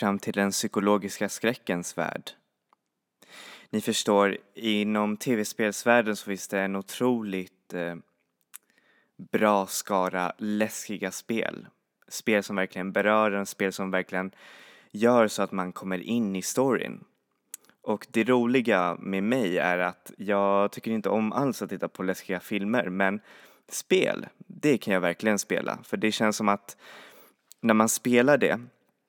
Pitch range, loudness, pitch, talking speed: 95-110 Hz, -27 LUFS, 105 Hz, 140 wpm